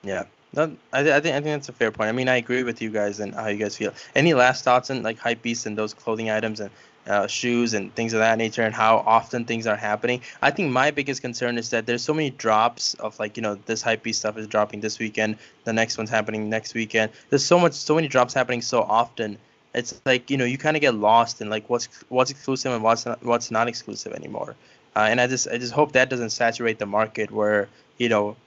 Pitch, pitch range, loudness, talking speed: 115 Hz, 110-125 Hz, -23 LUFS, 250 wpm